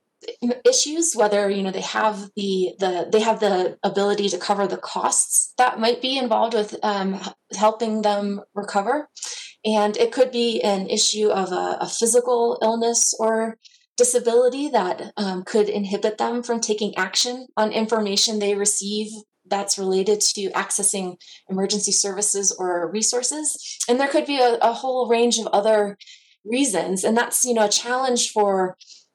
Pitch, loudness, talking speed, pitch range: 215 Hz, -21 LUFS, 155 wpm, 200-240 Hz